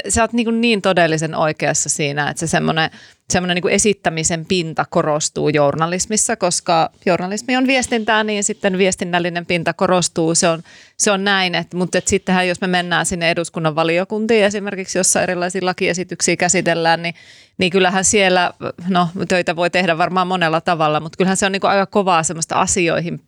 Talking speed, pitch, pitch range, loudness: 170 wpm, 180 Hz, 170-195 Hz, -17 LUFS